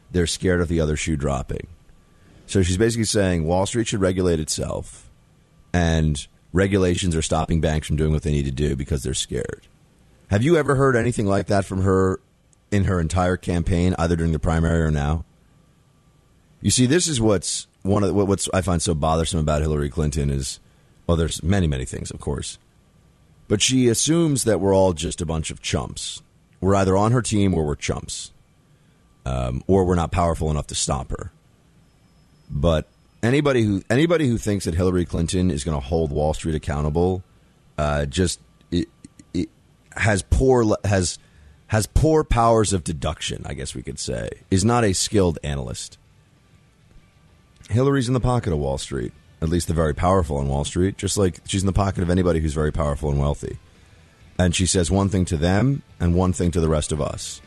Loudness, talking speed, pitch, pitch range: -22 LUFS, 195 wpm, 90 Hz, 80-100 Hz